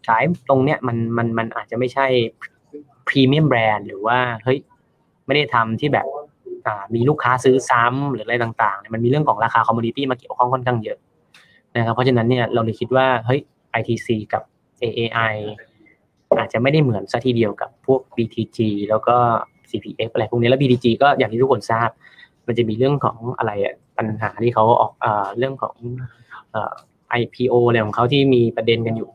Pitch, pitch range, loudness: 120 Hz, 115-130 Hz, -19 LUFS